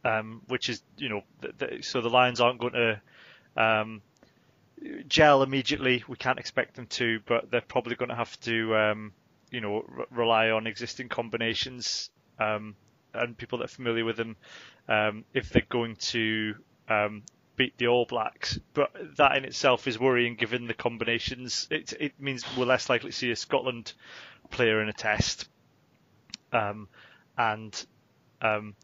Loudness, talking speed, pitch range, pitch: -28 LUFS, 165 wpm, 110-125 Hz, 115 Hz